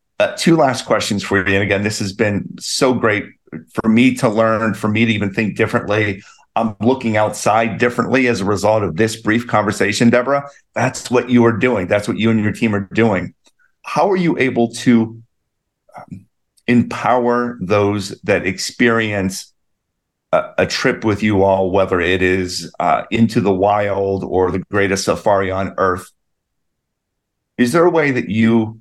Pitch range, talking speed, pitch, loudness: 100-120 Hz, 170 wpm, 110 Hz, -16 LUFS